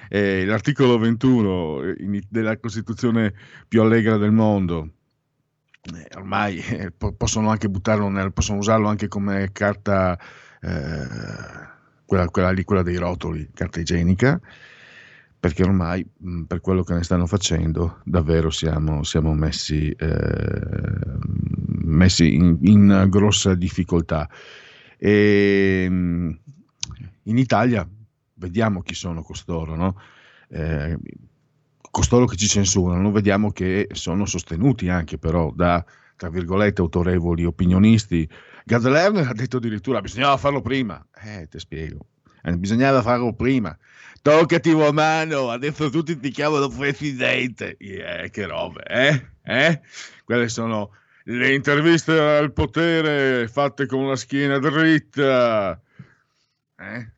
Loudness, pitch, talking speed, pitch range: -20 LUFS, 100 Hz, 120 wpm, 90-125 Hz